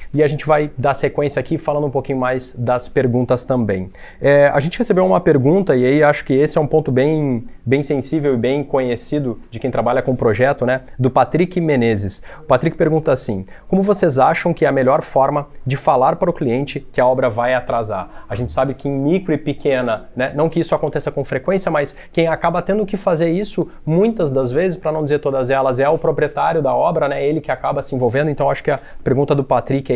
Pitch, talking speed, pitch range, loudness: 145 Hz, 230 wpm, 130-155 Hz, -17 LUFS